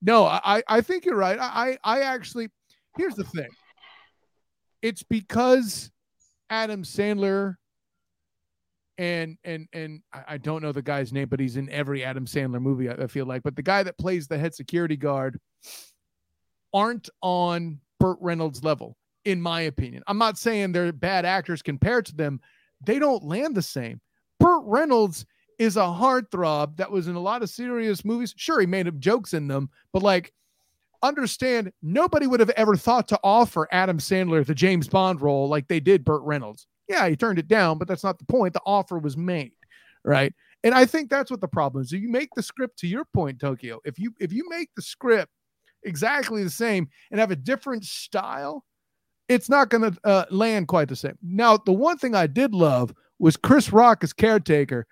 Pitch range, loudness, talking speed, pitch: 155-225 Hz, -23 LUFS, 190 wpm, 185 Hz